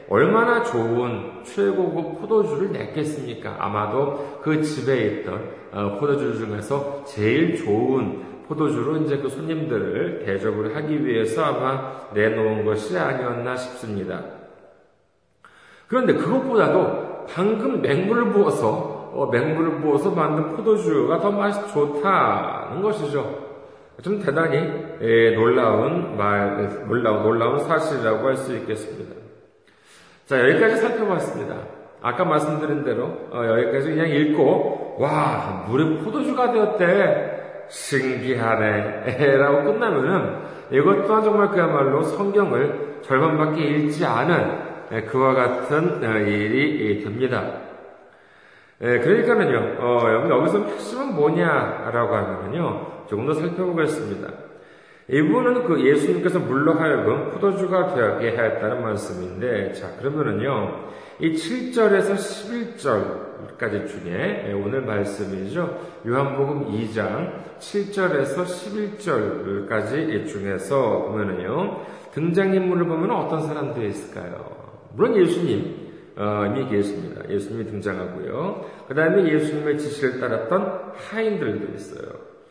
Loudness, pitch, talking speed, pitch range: -22 LUFS, 145 Hz, 265 characters per minute, 115-185 Hz